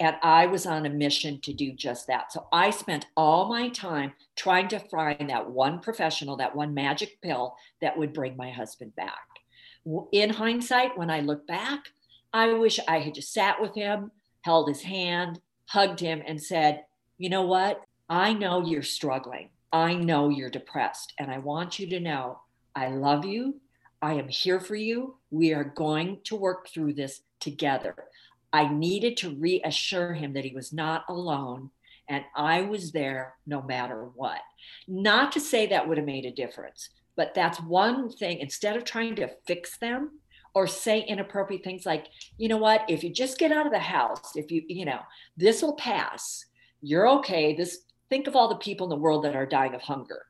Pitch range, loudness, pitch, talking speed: 145-205 Hz, -27 LUFS, 165 Hz, 190 wpm